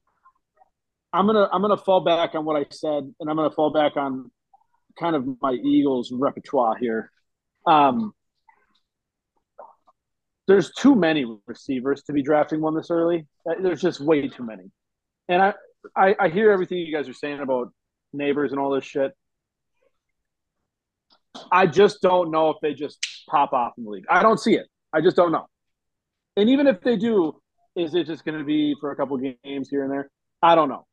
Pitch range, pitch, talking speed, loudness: 140-190 Hz, 155 Hz, 180 wpm, -22 LUFS